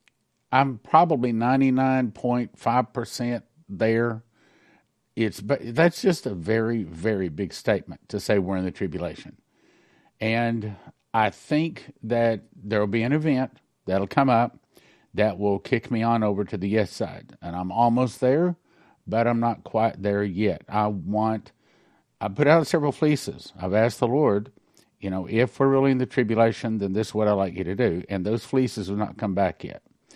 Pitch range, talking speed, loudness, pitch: 105-125 Hz, 175 wpm, -24 LUFS, 115 Hz